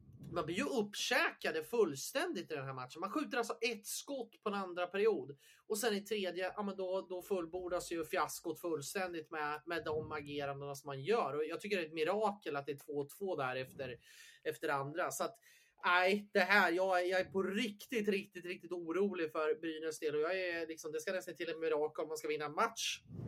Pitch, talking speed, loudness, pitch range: 180 Hz, 220 wpm, -38 LUFS, 155-205 Hz